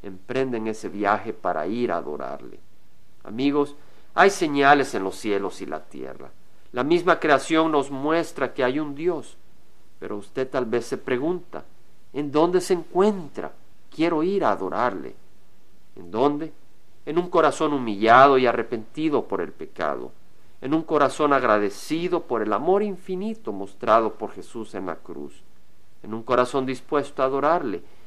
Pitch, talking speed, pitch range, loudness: 145 Hz, 150 wpm, 120-165 Hz, -23 LUFS